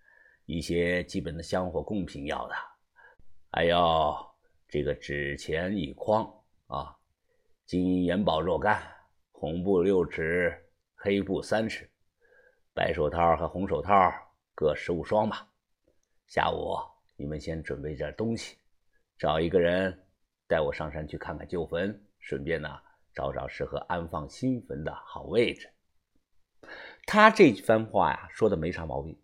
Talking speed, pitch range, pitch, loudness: 195 characters per minute, 80-95 Hz, 85 Hz, -29 LUFS